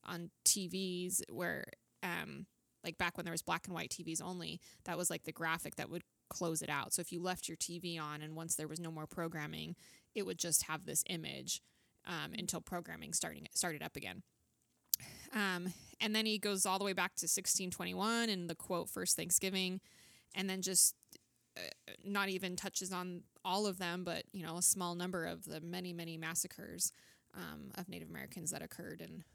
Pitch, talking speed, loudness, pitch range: 175 Hz, 195 wpm, -38 LUFS, 165-190 Hz